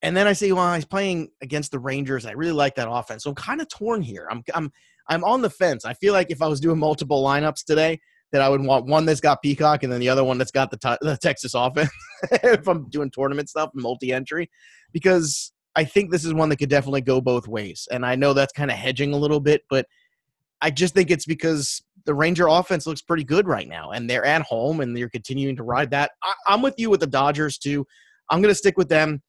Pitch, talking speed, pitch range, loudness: 150 Hz, 250 wpm, 135-170 Hz, -22 LUFS